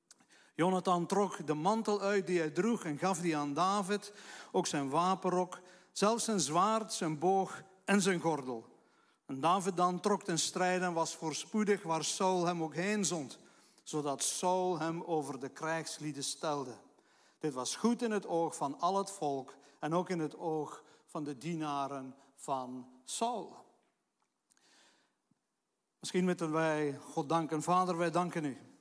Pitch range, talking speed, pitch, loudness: 150-185 Hz, 155 wpm, 170 Hz, -34 LUFS